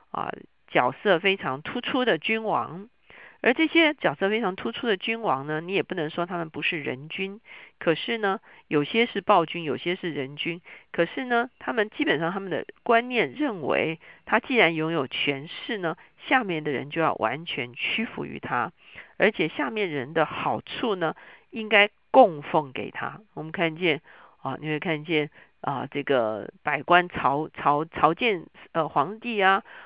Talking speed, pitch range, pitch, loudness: 245 characters per minute, 155-225 Hz, 180 Hz, -25 LUFS